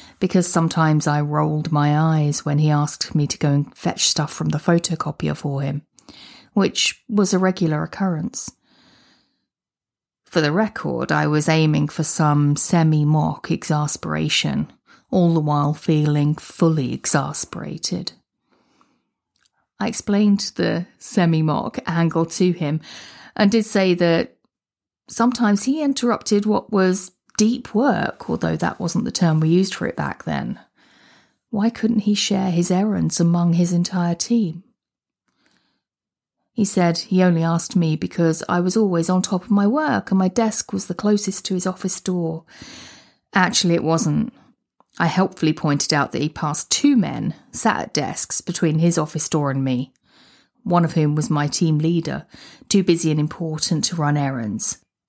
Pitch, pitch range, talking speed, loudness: 170 Hz, 150-190 Hz, 155 wpm, -20 LUFS